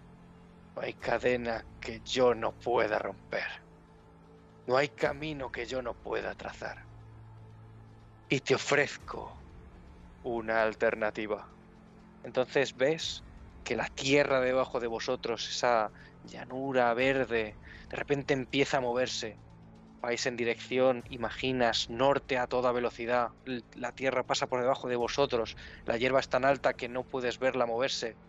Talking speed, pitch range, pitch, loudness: 130 wpm, 110-130 Hz, 125 Hz, -31 LUFS